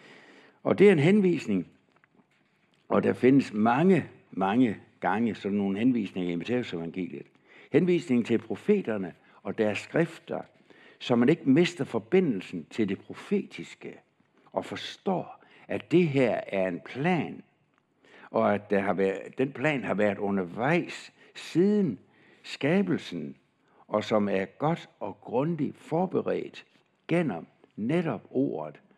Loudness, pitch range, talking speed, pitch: -27 LUFS, 100-165 Hz, 125 wpm, 120 Hz